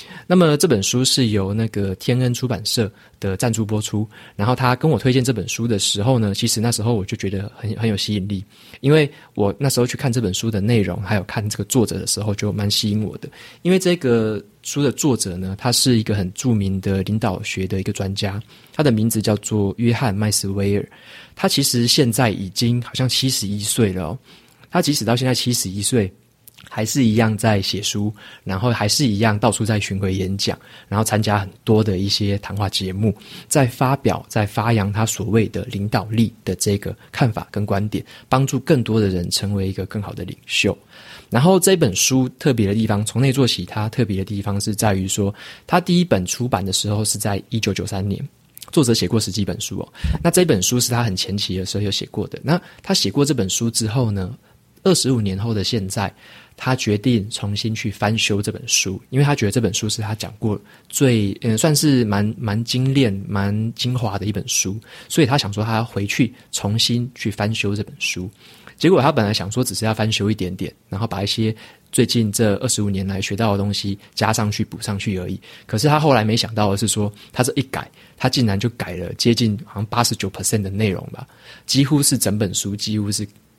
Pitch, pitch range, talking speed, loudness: 110 Hz, 100-125 Hz, 310 characters per minute, -19 LUFS